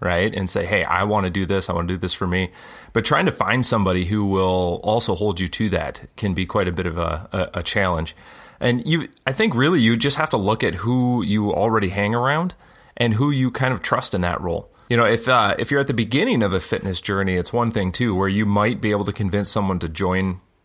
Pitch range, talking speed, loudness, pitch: 90-115 Hz, 260 wpm, -21 LUFS, 100 Hz